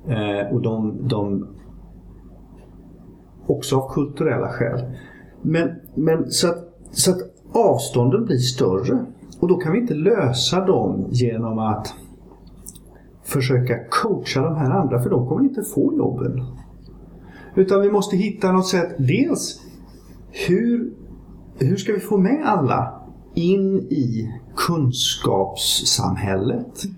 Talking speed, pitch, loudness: 120 wpm, 125 Hz, -20 LUFS